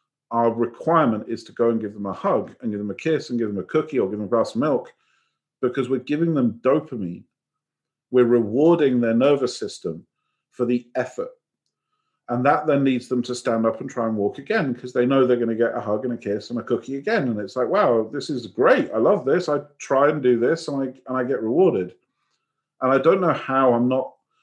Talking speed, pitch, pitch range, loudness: 240 wpm, 125 Hz, 115-135 Hz, -22 LUFS